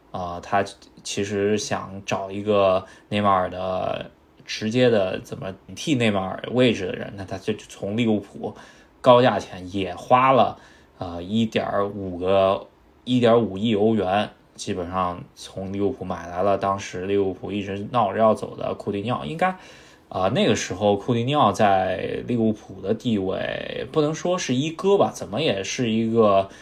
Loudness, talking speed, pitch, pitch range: -23 LUFS, 245 characters per minute, 100 Hz, 95-115 Hz